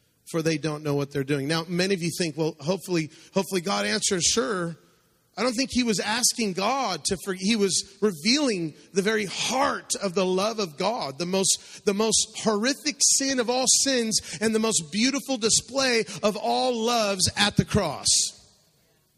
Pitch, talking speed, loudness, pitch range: 200 Hz, 180 wpm, -24 LUFS, 175-230 Hz